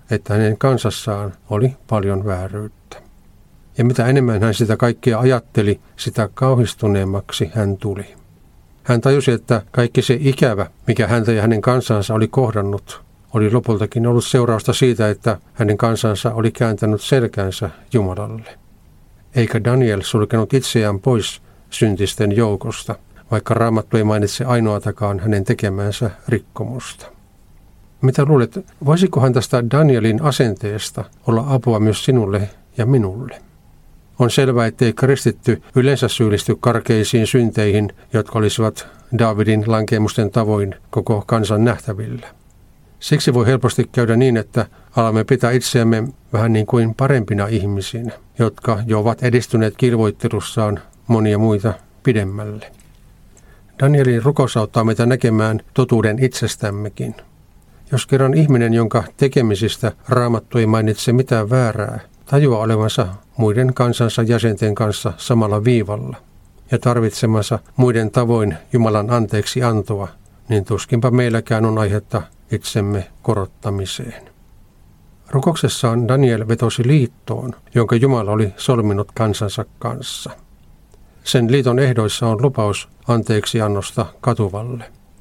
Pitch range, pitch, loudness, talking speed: 105-125 Hz, 115 Hz, -17 LUFS, 115 wpm